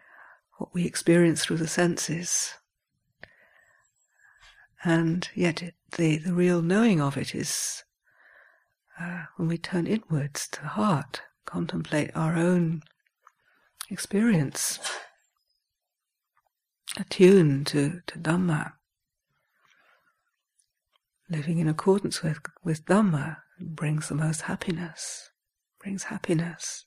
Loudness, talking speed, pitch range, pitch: -26 LUFS, 100 wpm, 160-185 Hz, 170 Hz